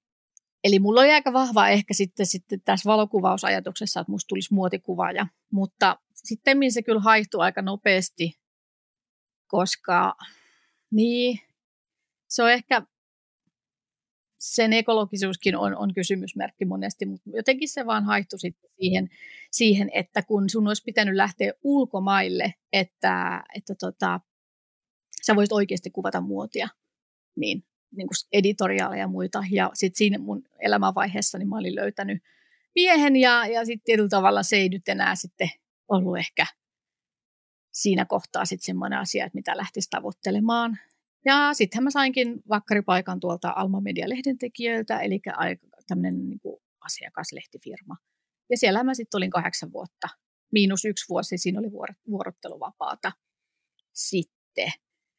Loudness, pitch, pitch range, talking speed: -24 LUFS, 200 Hz, 185-230 Hz, 130 wpm